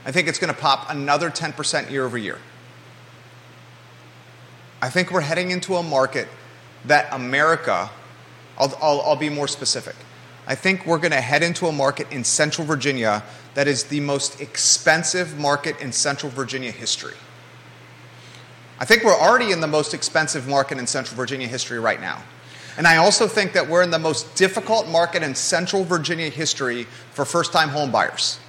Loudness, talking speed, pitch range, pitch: -20 LUFS, 170 wpm, 130-165 Hz, 145 Hz